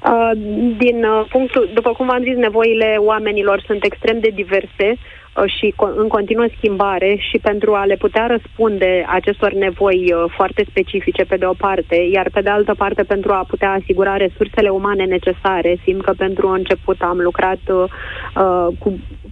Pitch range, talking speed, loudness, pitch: 190-220 Hz, 170 wpm, -16 LUFS, 200 Hz